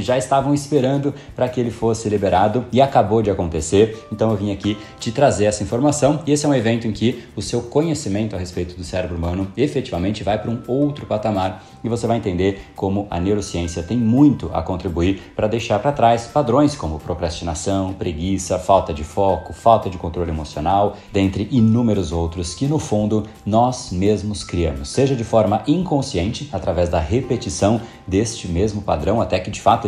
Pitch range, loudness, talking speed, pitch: 95-120 Hz, -19 LUFS, 180 wpm, 105 Hz